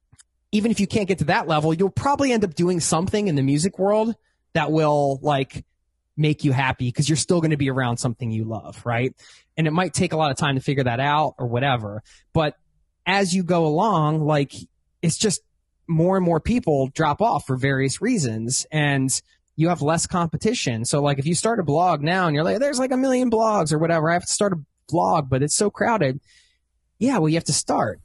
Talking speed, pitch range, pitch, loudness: 225 wpm, 135-185 Hz, 155 Hz, -21 LUFS